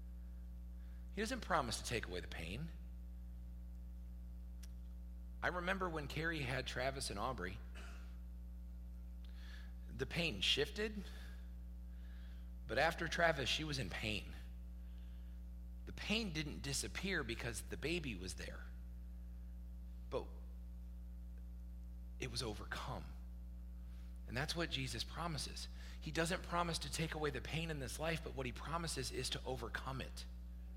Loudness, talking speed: -44 LUFS, 125 wpm